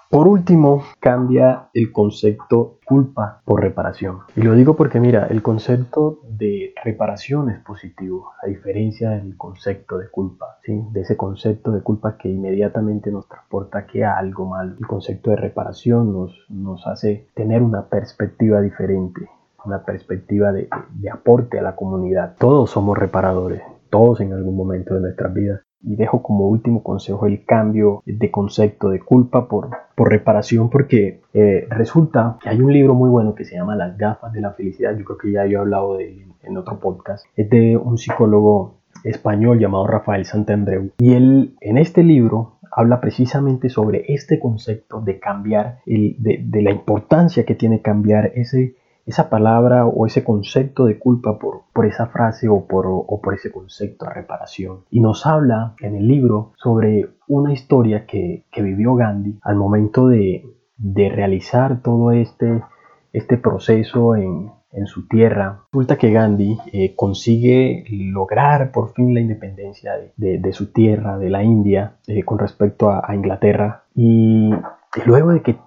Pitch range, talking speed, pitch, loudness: 100-120 Hz, 170 wpm, 110 Hz, -17 LUFS